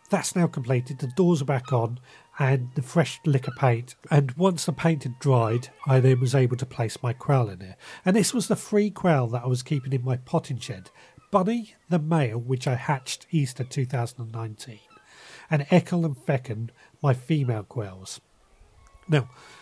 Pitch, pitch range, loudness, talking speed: 135 Hz, 125-160 Hz, -25 LUFS, 180 wpm